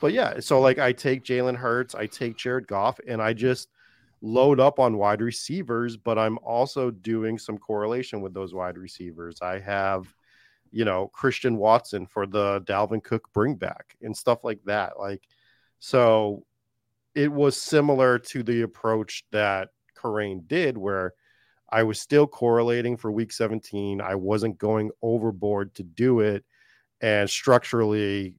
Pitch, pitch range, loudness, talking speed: 110 Hz, 100-120 Hz, -25 LUFS, 155 wpm